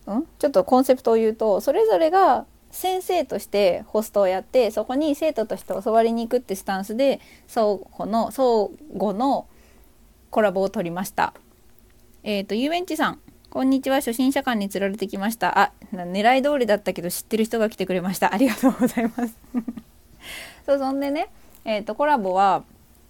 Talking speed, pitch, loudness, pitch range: 340 characters per minute, 225 Hz, -22 LUFS, 195-265 Hz